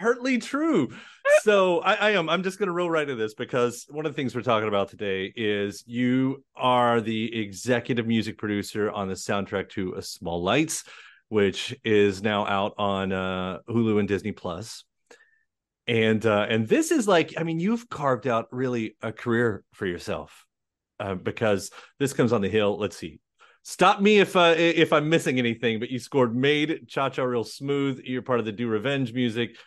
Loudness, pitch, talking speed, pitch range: -25 LUFS, 120 Hz, 190 wpm, 105-155 Hz